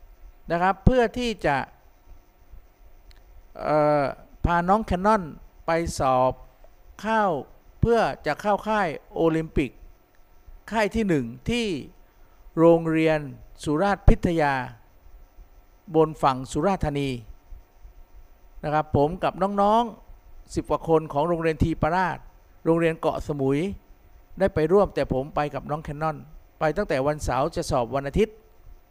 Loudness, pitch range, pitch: -24 LUFS, 130-180 Hz, 155 Hz